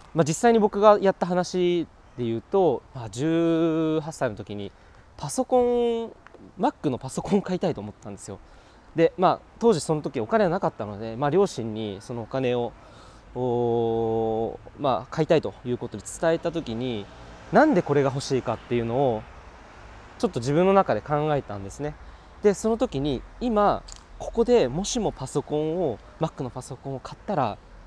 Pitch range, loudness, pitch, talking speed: 115-180 Hz, -25 LUFS, 140 Hz, 325 characters per minute